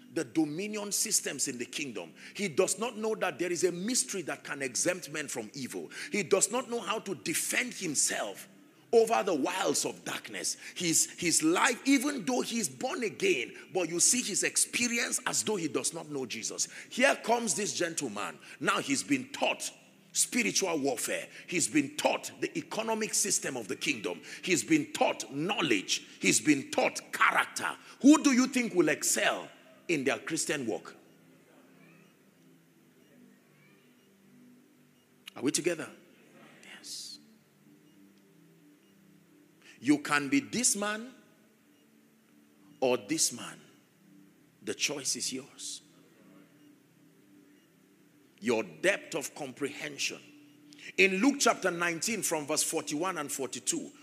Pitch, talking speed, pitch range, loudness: 190 Hz, 135 wpm, 150-250 Hz, -30 LUFS